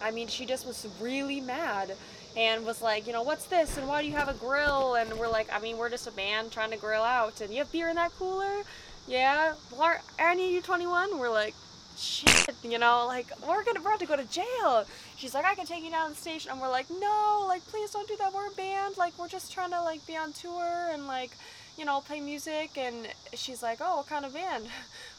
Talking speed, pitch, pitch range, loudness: 250 wpm, 290 Hz, 240-350 Hz, -30 LUFS